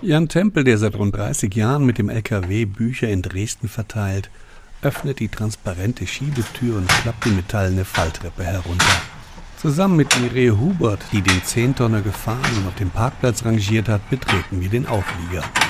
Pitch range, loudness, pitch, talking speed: 95-125 Hz, -20 LUFS, 110 Hz, 160 wpm